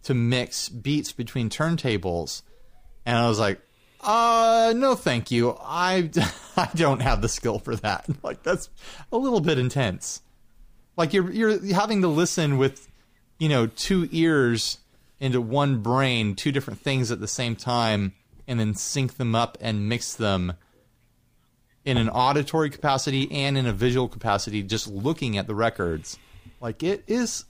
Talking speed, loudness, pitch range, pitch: 160 wpm, -24 LUFS, 115-150 Hz, 125 Hz